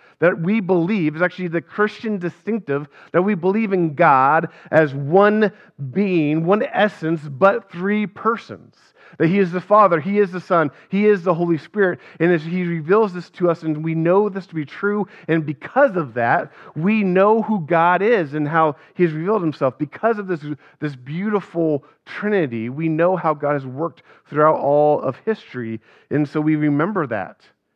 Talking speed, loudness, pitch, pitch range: 185 wpm, -19 LUFS, 175 Hz, 155-200 Hz